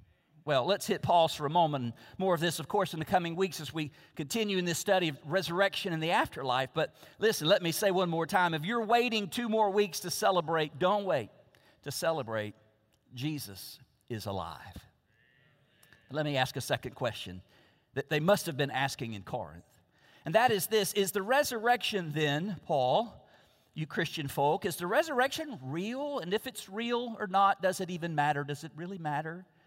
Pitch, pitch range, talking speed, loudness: 165 Hz, 140-200 Hz, 190 wpm, -31 LUFS